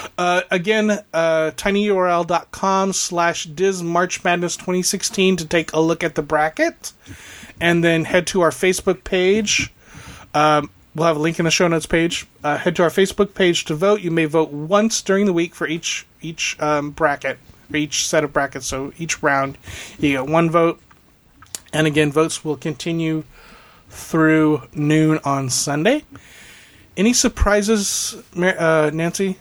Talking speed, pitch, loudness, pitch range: 155 wpm, 165 Hz, -18 LUFS, 155-185 Hz